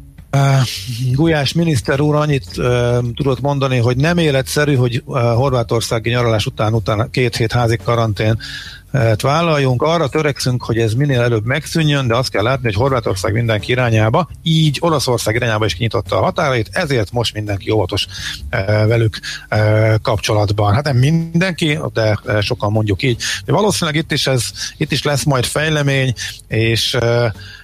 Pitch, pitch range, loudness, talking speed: 120 Hz, 110-140 Hz, -16 LUFS, 155 wpm